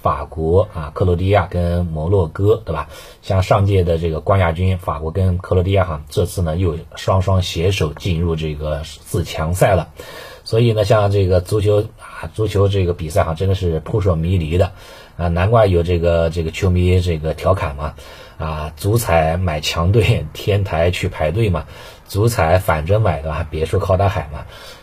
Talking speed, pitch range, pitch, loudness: 265 characters per minute, 80-100 Hz, 90 Hz, -18 LUFS